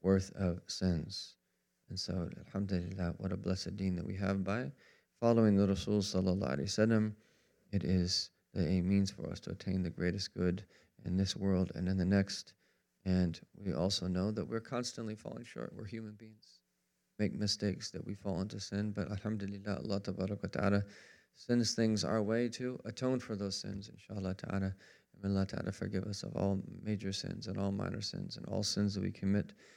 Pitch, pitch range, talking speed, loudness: 100 Hz, 95-105 Hz, 180 wpm, -36 LUFS